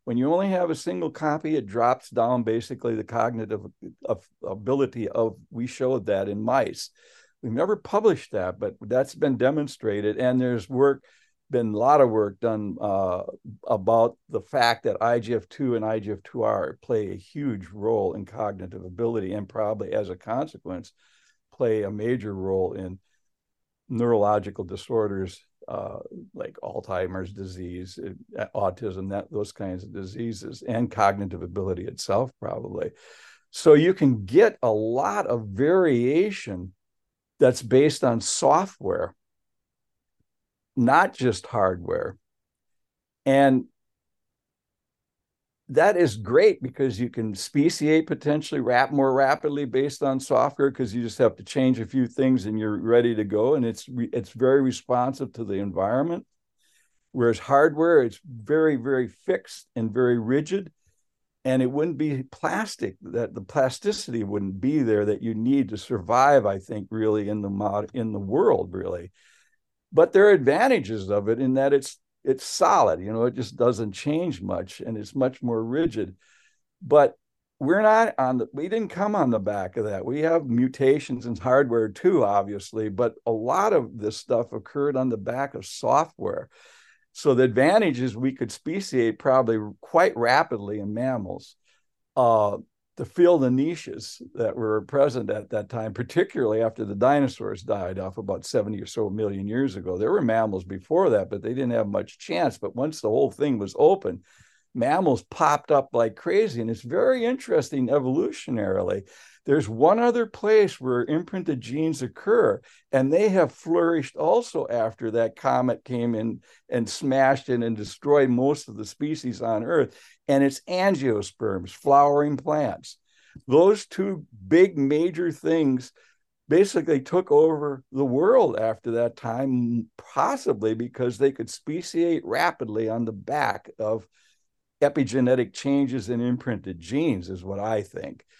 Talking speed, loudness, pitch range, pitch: 155 wpm, -24 LUFS, 110-145 Hz, 125 Hz